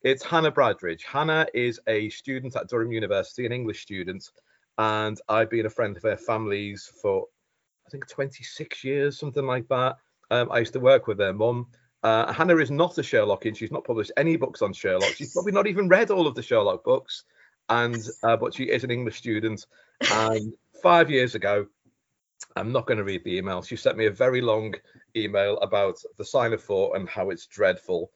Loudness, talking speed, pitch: -25 LUFS, 200 wpm, 130 Hz